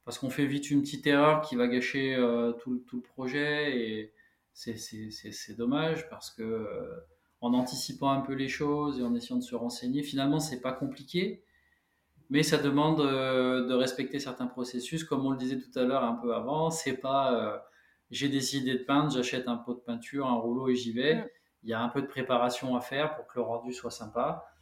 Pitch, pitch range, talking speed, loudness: 130 Hz, 120-140 Hz, 210 wpm, -31 LUFS